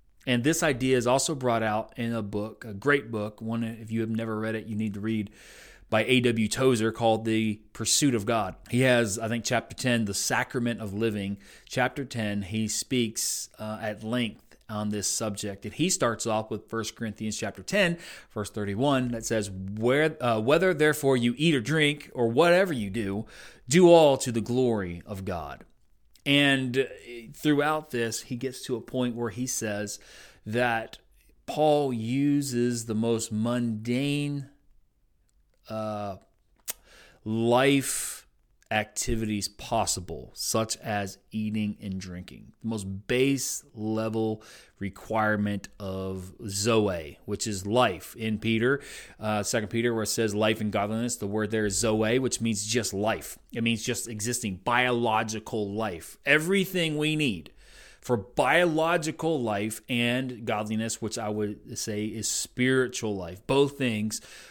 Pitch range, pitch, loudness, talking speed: 105-125 Hz, 115 Hz, -27 LUFS, 155 wpm